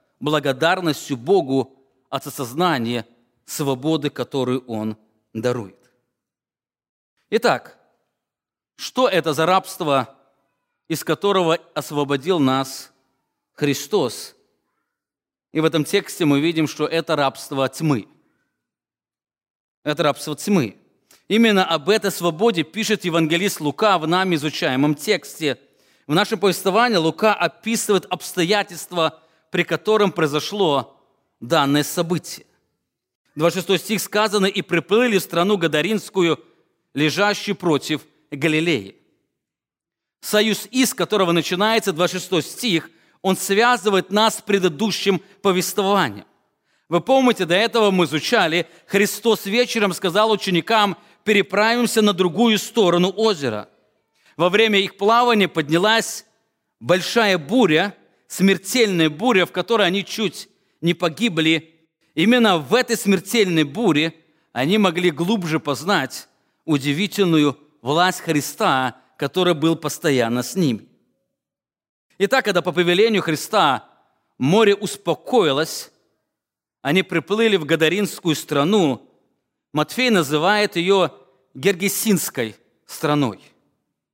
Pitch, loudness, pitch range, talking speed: 175 Hz, -19 LUFS, 150-200 Hz, 100 wpm